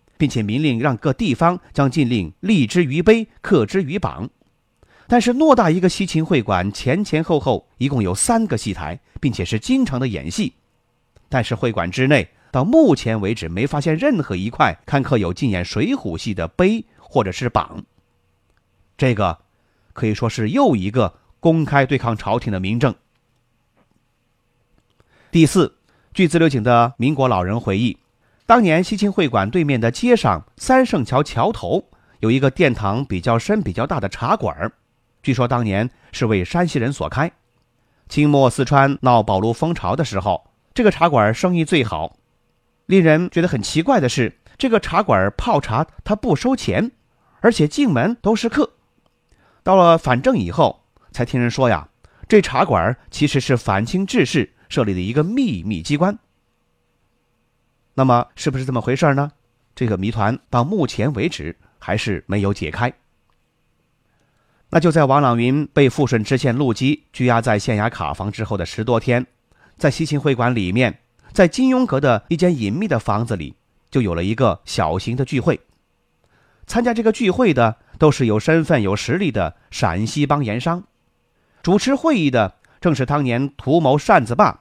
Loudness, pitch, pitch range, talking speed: -18 LUFS, 125 Hz, 110-160 Hz, 245 characters per minute